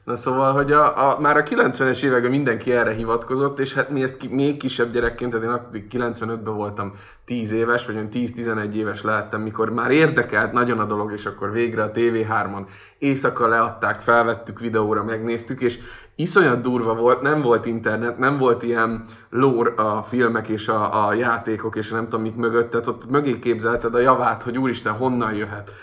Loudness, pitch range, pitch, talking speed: -21 LUFS, 110-125 Hz, 115 Hz, 185 wpm